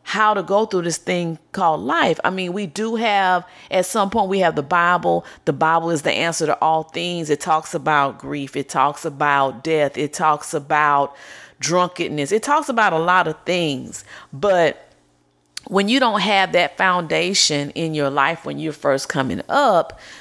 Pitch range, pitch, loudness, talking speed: 145-185 Hz, 165 Hz, -19 LUFS, 185 wpm